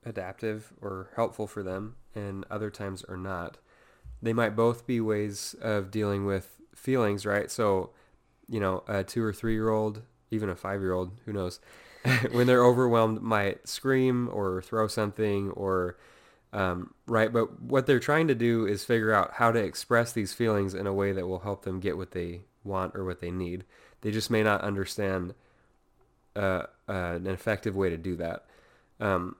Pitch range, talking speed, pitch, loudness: 95-115 Hz, 185 wpm, 105 Hz, -29 LUFS